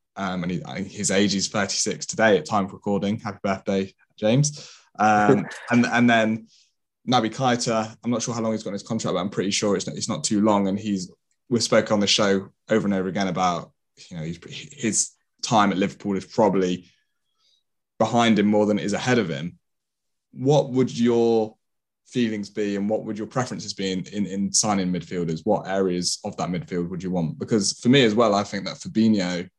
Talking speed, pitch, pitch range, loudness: 210 wpm, 105 Hz, 95-110 Hz, -23 LUFS